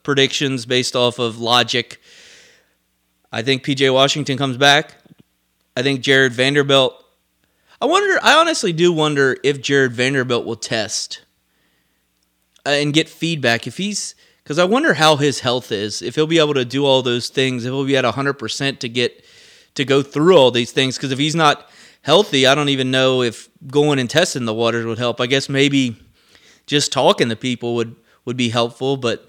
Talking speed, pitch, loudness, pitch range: 185 wpm, 135 Hz, -16 LUFS, 120-145 Hz